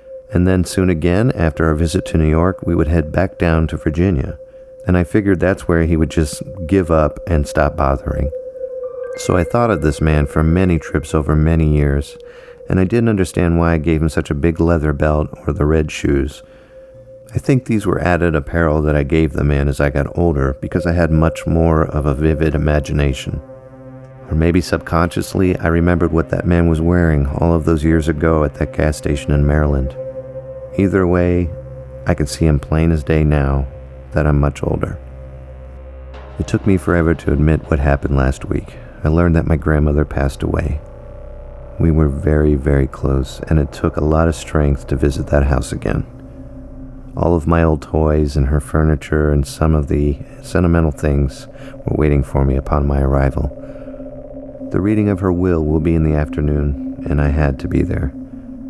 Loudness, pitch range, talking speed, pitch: -16 LUFS, 75-90 Hz, 195 wpm, 80 Hz